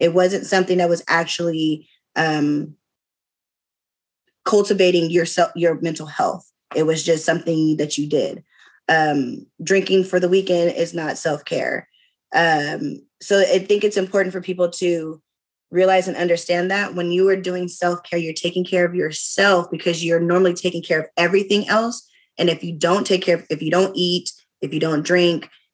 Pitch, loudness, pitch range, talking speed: 175 Hz, -19 LUFS, 165-185 Hz, 175 wpm